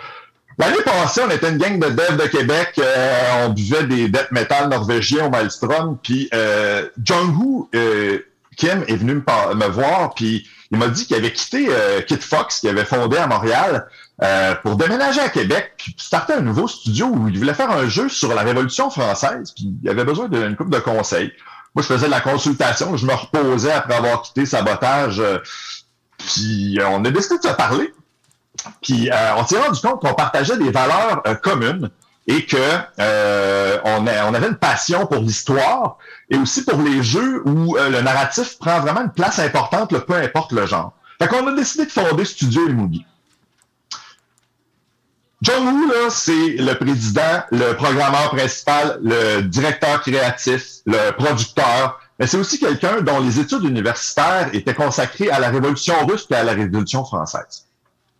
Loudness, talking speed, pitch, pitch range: -17 LUFS, 185 wpm, 130 Hz, 115-160 Hz